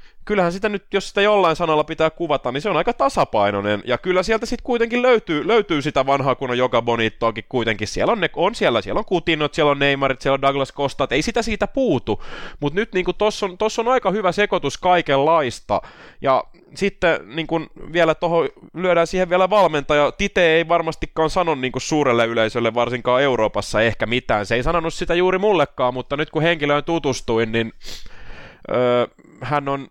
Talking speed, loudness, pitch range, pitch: 185 wpm, -19 LUFS, 130-185 Hz, 160 Hz